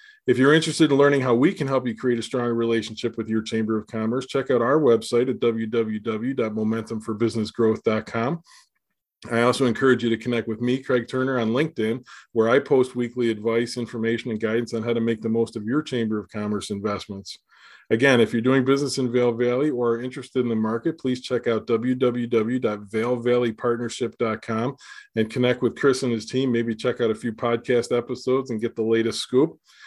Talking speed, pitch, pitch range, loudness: 190 wpm, 120 Hz, 115-125 Hz, -23 LUFS